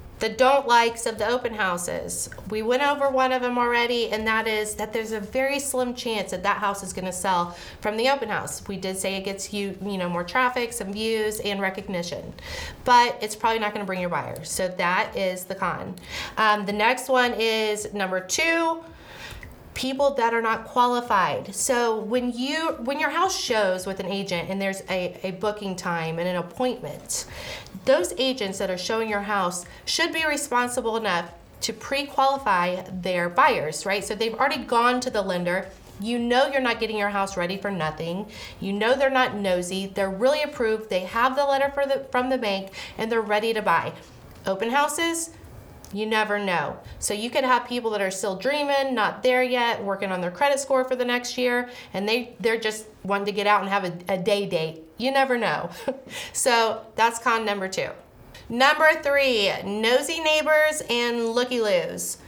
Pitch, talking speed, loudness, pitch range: 225 Hz, 195 wpm, -24 LUFS, 195-255 Hz